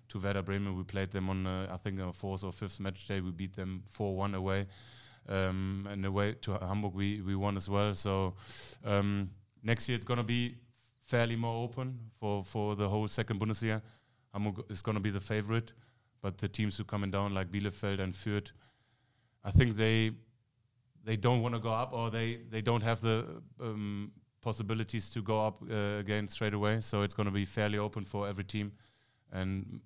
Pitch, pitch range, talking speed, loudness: 105 Hz, 100-115 Hz, 205 wpm, -35 LUFS